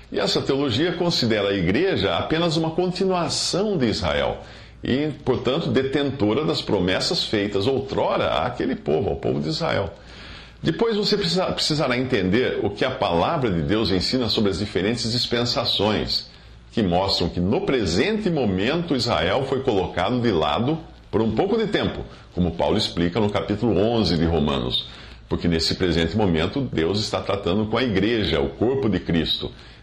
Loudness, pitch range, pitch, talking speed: -22 LUFS, 90-140 Hz, 110 Hz, 155 wpm